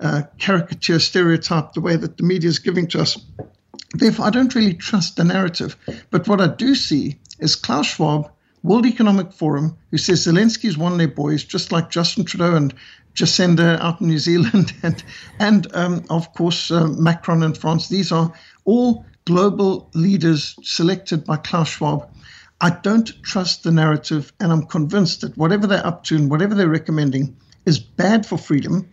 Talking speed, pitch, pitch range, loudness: 180 wpm, 170 Hz, 160-190 Hz, -18 LUFS